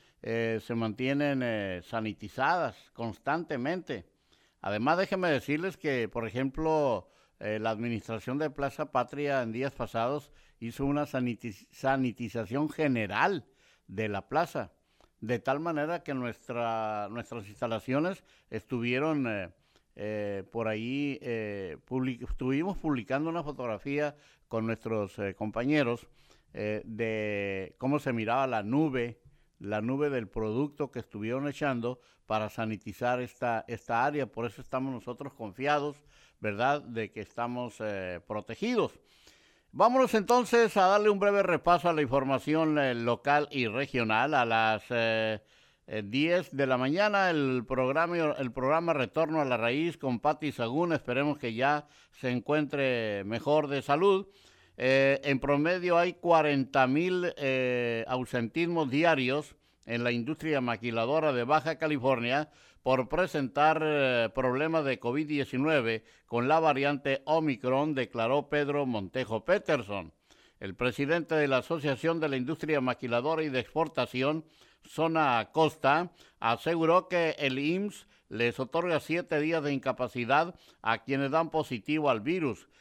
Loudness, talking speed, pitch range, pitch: -30 LUFS, 130 wpm, 115-150 Hz, 135 Hz